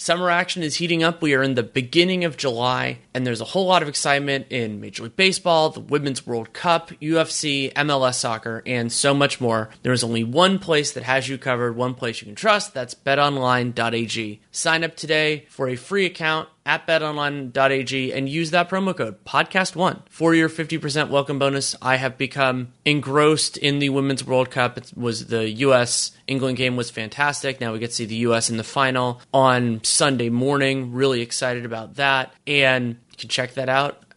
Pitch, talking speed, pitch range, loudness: 135 Hz, 195 wpm, 120-155 Hz, -21 LUFS